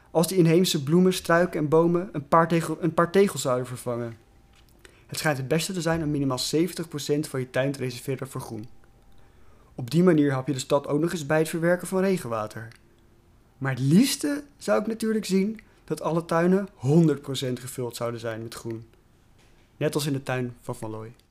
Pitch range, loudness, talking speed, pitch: 120-170 Hz, -25 LUFS, 195 wpm, 145 Hz